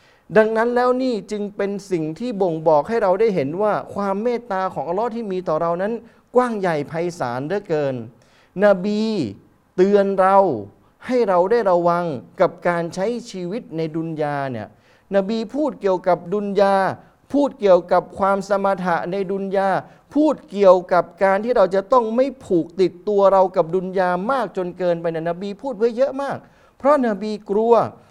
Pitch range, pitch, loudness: 175-220 Hz, 195 Hz, -20 LUFS